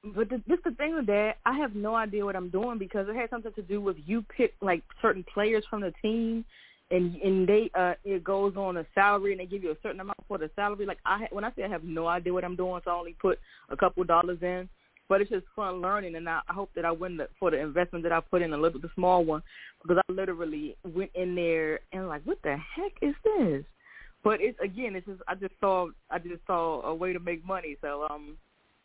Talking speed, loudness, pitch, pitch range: 255 wpm, -30 LUFS, 190 Hz, 175-210 Hz